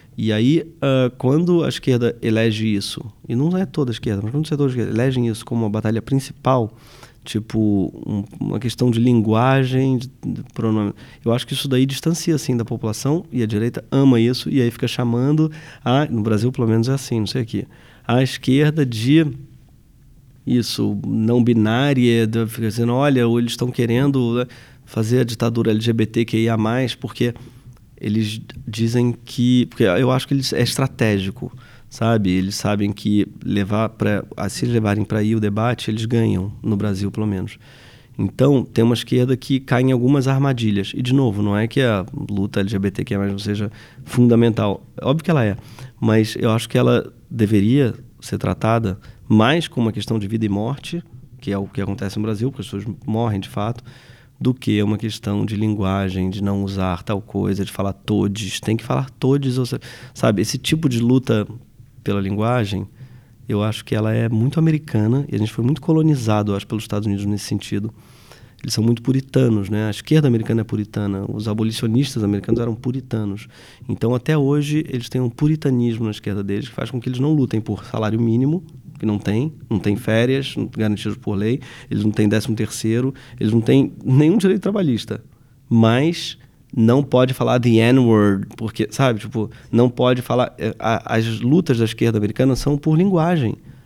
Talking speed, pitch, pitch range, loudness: 185 wpm, 115 Hz, 110-130 Hz, -19 LUFS